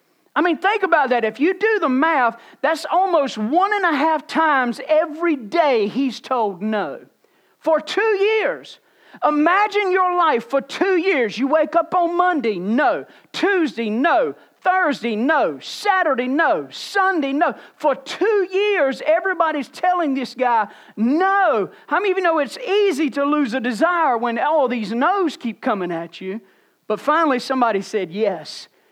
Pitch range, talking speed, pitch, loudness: 245-360 Hz, 160 wpm, 305 Hz, -19 LUFS